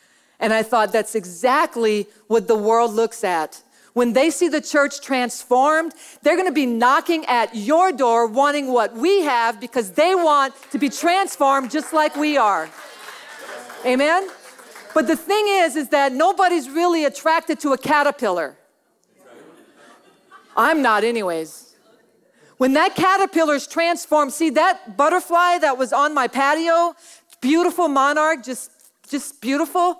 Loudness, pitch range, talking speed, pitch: -19 LUFS, 245-330 Hz, 140 wpm, 285 Hz